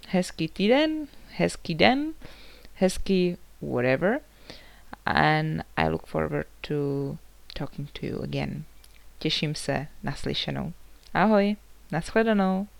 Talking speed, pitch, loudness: 90 wpm, 155 Hz, -27 LUFS